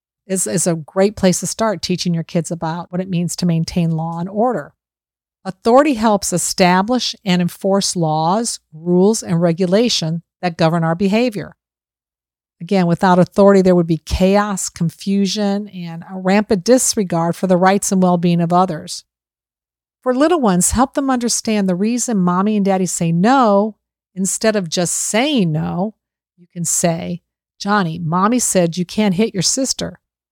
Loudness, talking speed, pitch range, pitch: -16 LUFS, 160 wpm, 170-205 Hz, 185 Hz